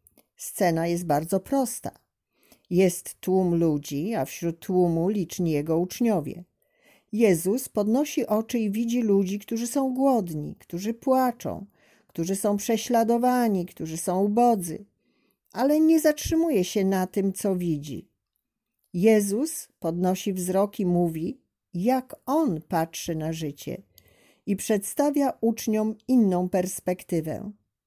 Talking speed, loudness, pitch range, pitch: 115 wpm, -25 LUFS, 175-235 Hz, 200 Hz